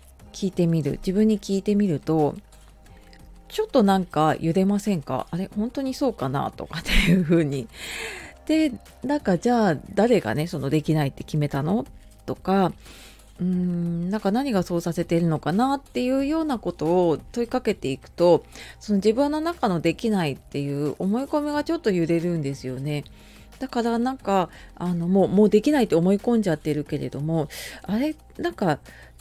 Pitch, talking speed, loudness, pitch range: 185 Hz, 350 characters per minute, -24 LUFS, 155-230 Hz